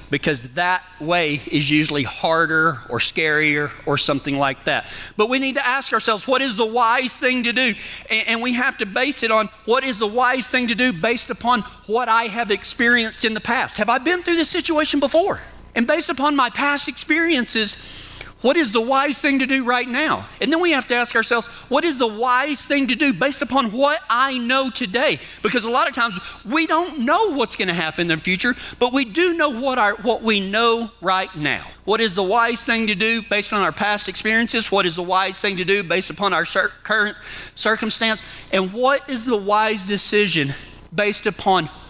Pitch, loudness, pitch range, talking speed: 230 Hz, -19 LUFS, 200-260 Hz, 210 wpm